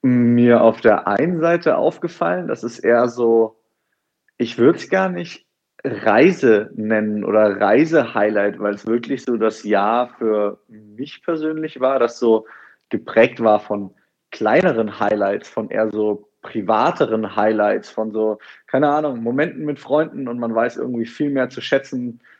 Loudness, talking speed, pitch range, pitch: -18 LUFS, 150 wpm, 105-130 Hz, 115 Hz